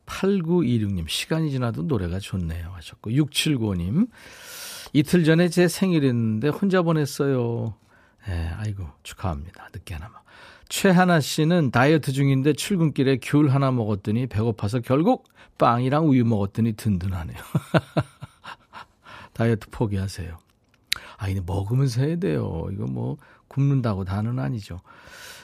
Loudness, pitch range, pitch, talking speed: -23 LUFS, 105-155 Hz, 125 Hz, 285 characters per minute